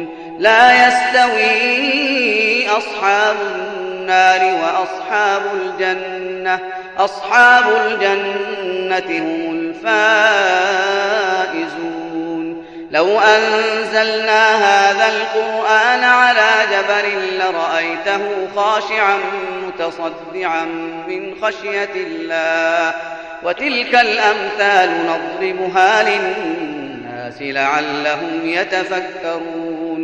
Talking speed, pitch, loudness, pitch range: 55 wpm, 200 Hz, -15 LUFS, 175-220 Hz